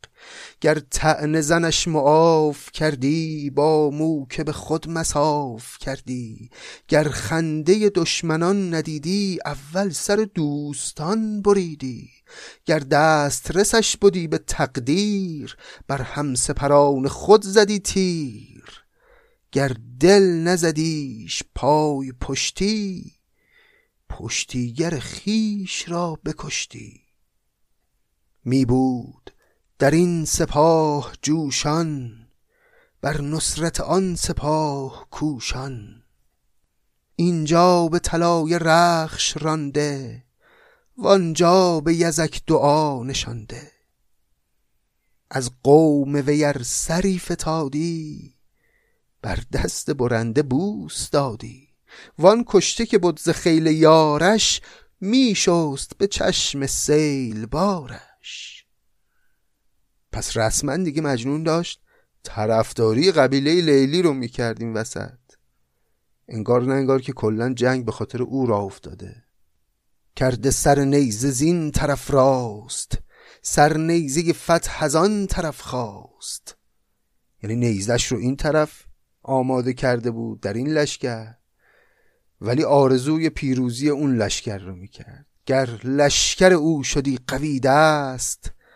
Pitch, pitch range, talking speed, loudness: 150 Hz, 125-170 Hz, 95 wpm, -20 LUFS